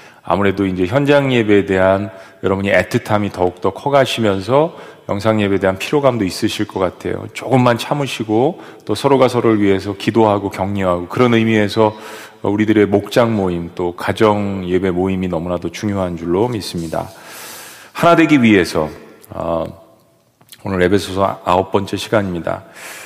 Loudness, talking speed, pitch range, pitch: -16 LUFS, 335 characters per minute, 95-115 Hz, 100 Hz